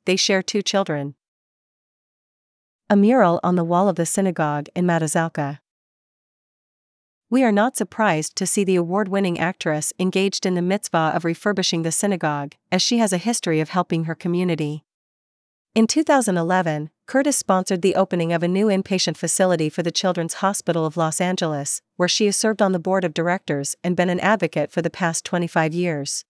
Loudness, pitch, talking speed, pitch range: -21 LUFS, 180 Hz, 175 wpm, 165-195 Hz